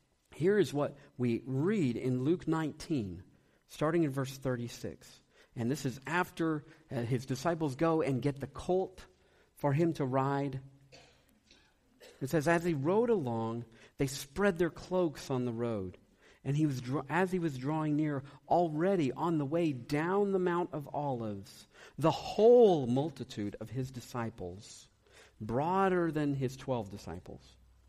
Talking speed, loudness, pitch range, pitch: 150 wpm, -33 LUFS, 120-165 Hz, 140 Hz